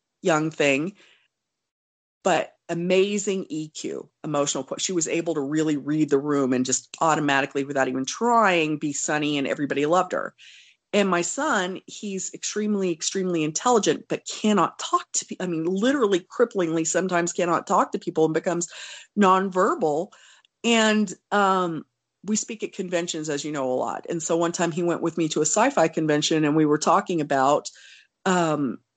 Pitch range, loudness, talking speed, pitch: 150-190 Hz, -23 LUFS, 165 wpm, 170 Hz